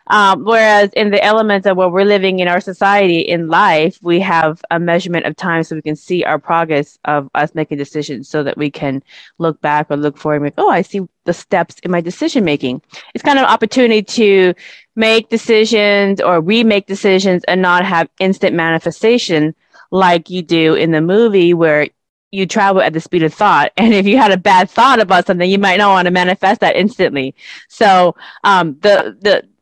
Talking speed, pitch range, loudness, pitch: 205 wpm, 160-200 Hz, -12 LUFS, 180 Hz